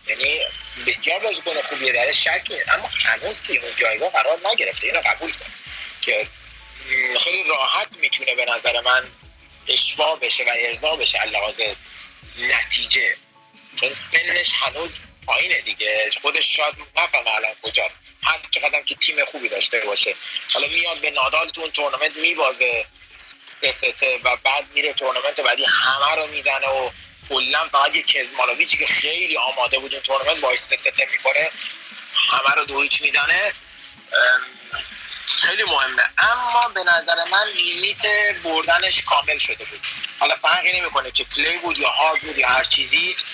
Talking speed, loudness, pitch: 150 wpm, -18 LUFS, 205 Hz